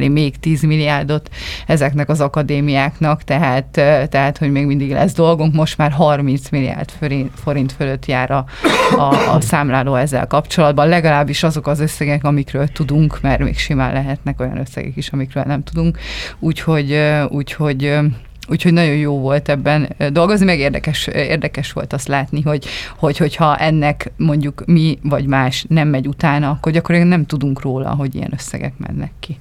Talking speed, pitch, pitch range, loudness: 160 wpm, 145 Hz, 140-155 Hz, -16 LUFS